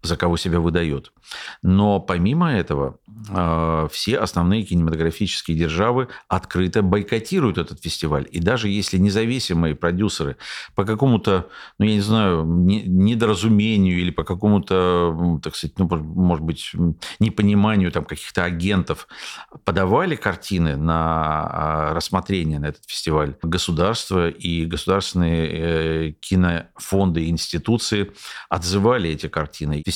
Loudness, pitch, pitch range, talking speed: -21 LUFS, 90 Hz, 80-100 Hz, 110 wpm